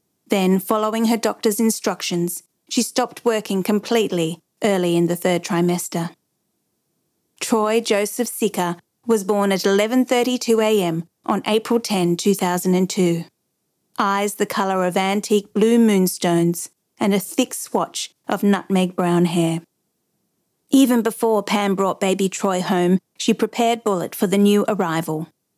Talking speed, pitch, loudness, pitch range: 125 wpm, 200 Hz, -20 LUFS, 180-220 Hz